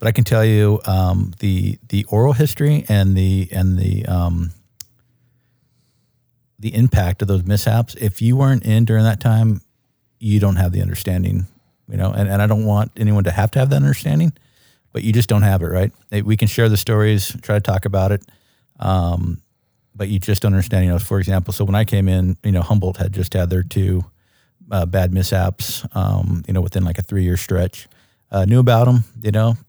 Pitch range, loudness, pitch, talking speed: 95-115 Hz, -18 LUFS, 105 Hz, 210 wpm